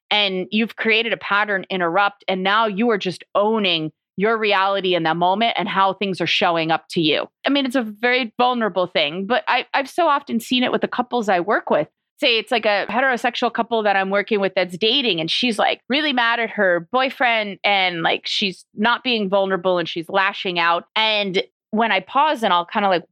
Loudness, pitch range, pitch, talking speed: -19 LUFS, 190-235 Hz, 210 Hz, 220 wpm